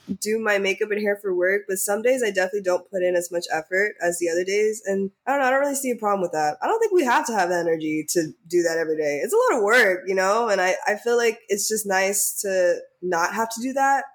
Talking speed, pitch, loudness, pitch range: 295 wpm, 195 Hz, -22 LUFS, 175-225 Hz